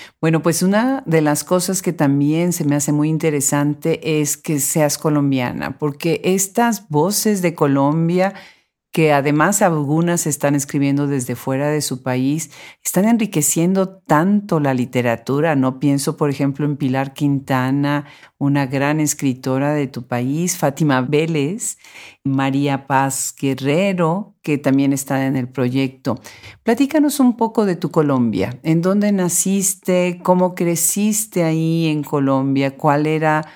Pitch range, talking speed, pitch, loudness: 140-175 Hz, 140 wpm, 150 Hz, -18 LUFS